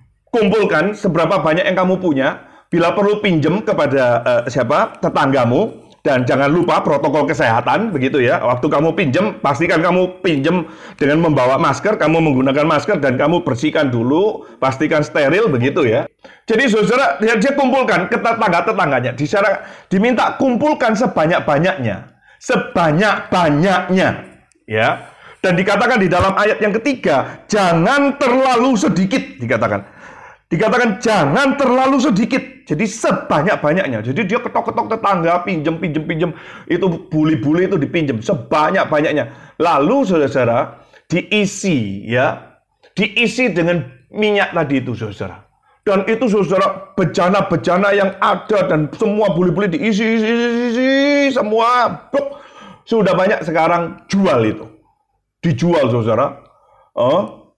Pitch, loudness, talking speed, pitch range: 195 Hz, -15 LUFS, 120 wpm, 165-230 Hz